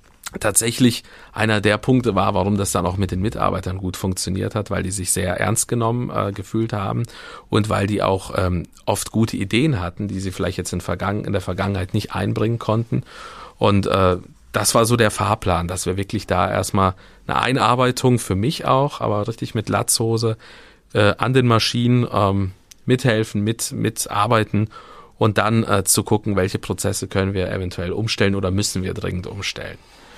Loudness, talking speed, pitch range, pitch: -20 LUFS, 180 wpm, 95-110 Hz, 100 Hz